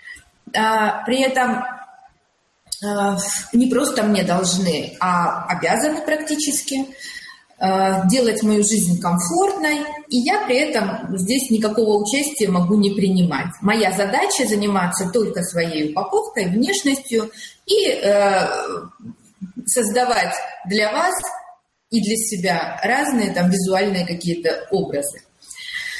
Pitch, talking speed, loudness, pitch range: 220 Hz, 95 wpm, -19 LUFS, 190-275 Hz